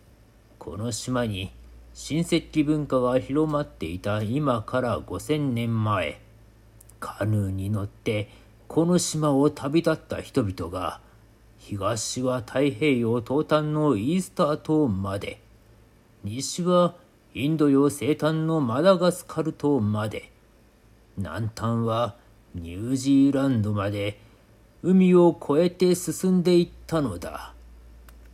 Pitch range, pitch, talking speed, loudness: 105-150 Hz, 120 Hz, 210 characters per minute, -24 LUFS